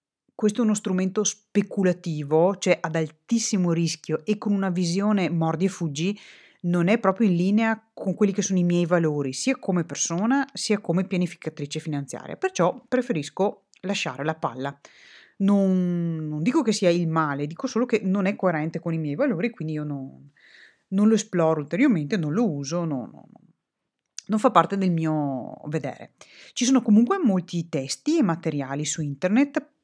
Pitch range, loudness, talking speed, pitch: 160-210 Hz, -24 LUFS, 170 wpm, 180 Hz